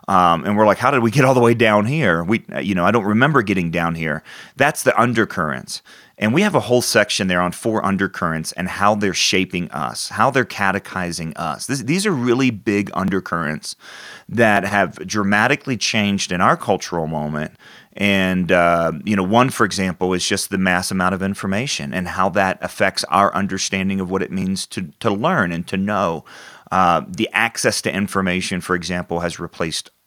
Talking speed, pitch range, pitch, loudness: 195 wpm, 90-105 Hz, 95 Hz, -18 LUFS